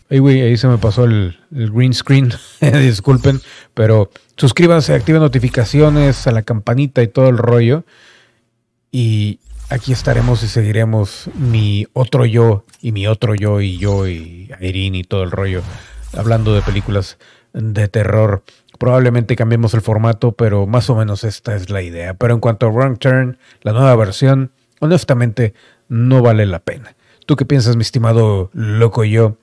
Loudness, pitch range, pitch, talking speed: -14 LUFS, 105-130 Hz, 115 Hz, 160 wpm